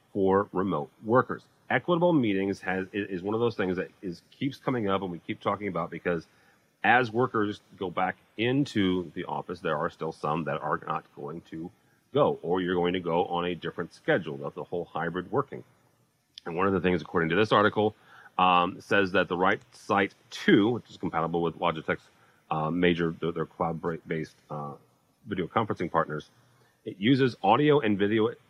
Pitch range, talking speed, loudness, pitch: 85-105 Hz, 185 wpm, -28 LUFS, 95 Hz